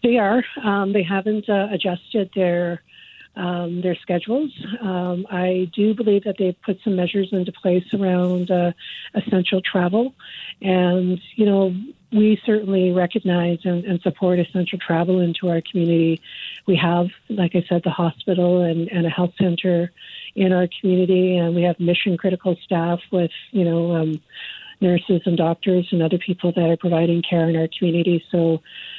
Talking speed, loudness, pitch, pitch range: 165 wpm, -20 LUFS, 180 Hz, 175-195 Hz